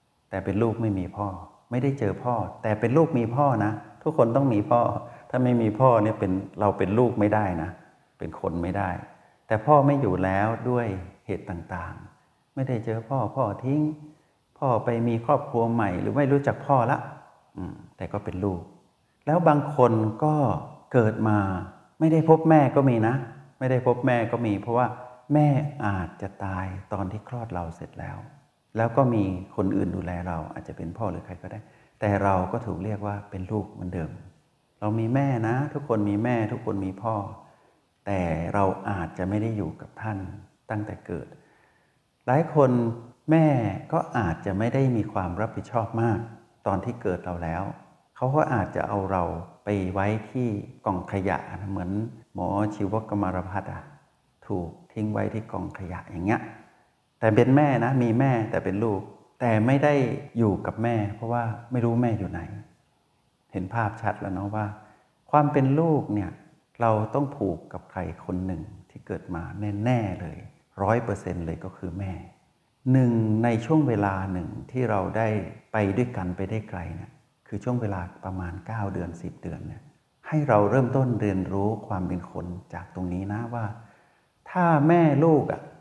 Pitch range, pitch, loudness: 95-125 Hz, 110 Hz, -26 LUFS